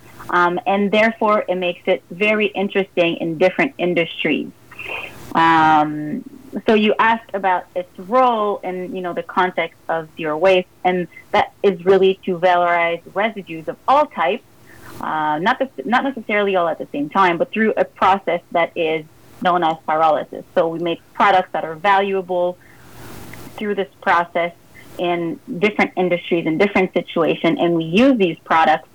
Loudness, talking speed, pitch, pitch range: -18 LUFS, 160 wpm, 180 Hz, 170-200 Hz